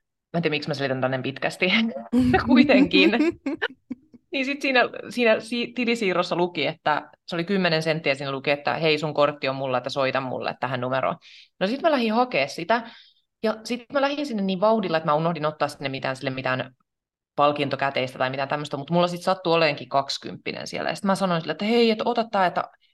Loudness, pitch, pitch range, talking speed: -23 LUFS, 175 Hz, 145-235 Hz, 200 wpm